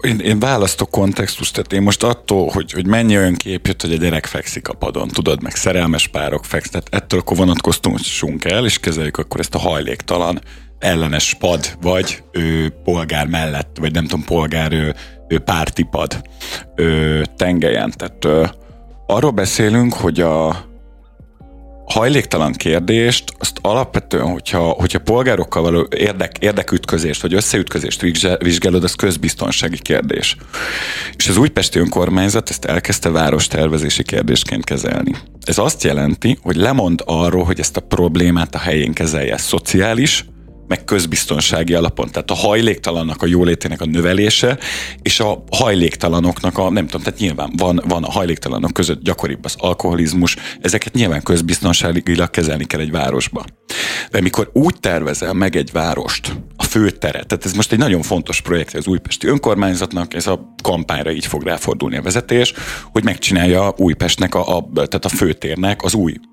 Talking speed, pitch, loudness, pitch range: 150 wpm, 90 Hz, -16 LUFS, 80-95 Hz